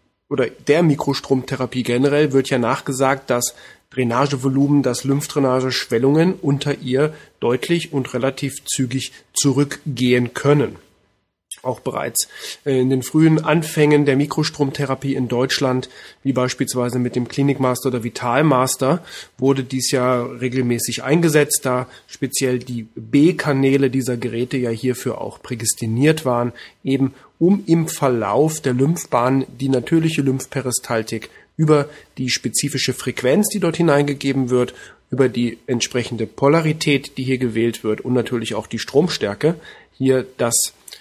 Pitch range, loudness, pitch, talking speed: 125-145 Hz, -19 LUFS, 135 Hz, 125 wpm